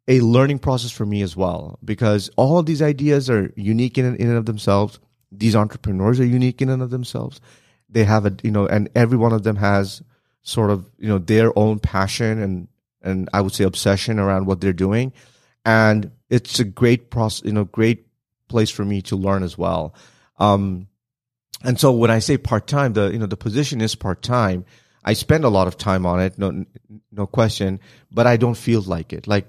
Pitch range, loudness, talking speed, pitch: 100-120 Hz, -19 LUFS, 205 wpm, 110 Hz